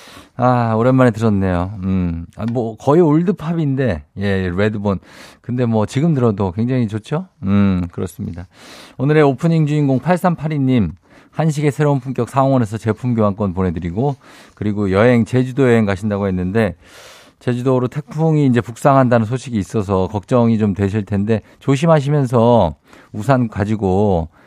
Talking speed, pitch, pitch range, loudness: 315 characters per minute, 115 Hz, 100-135 Hz, -17 LUFS